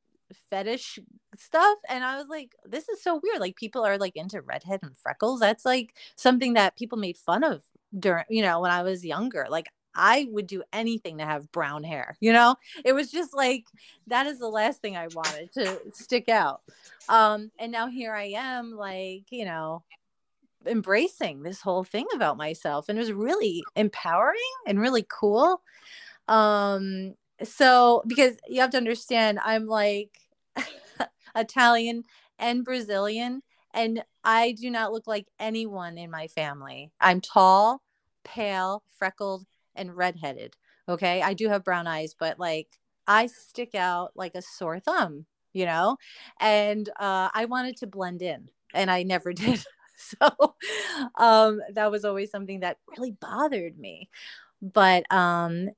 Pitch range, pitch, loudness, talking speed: 185-240 Hz, 210 Hz, -25 LUFS, 160 wpm